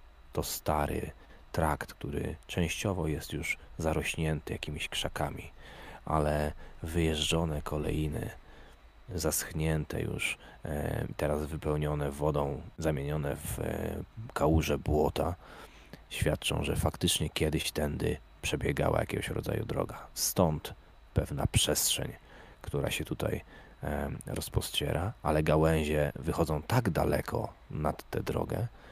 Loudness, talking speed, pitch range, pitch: -32 LUFS, 95 wpm, 75-85 Hz, 75 Hz